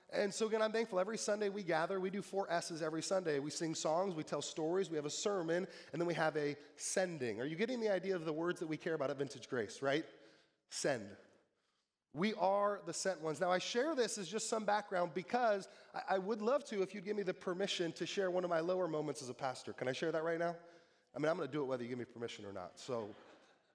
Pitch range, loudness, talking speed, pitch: 155-200 Hz, -39 LUFS, 265 wpm, 175 Hz